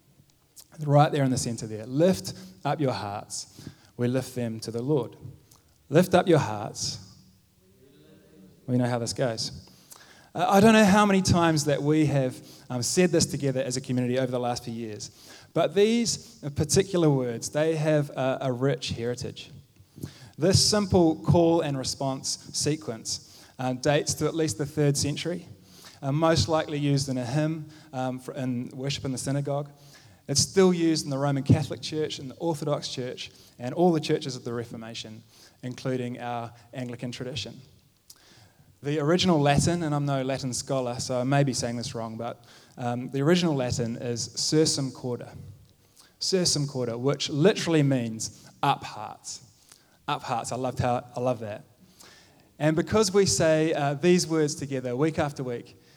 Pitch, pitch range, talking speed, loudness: 140 Hz, 125-155 Hz, 160 wpm, -26 LUFS